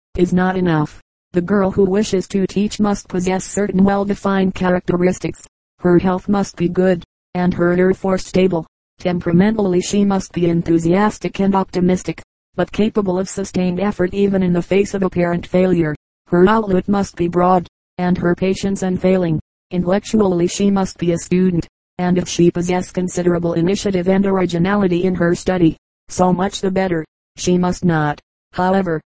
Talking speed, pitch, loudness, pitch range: 160 wpm, 185 Hz, -17 LUFS, 175-195 Hz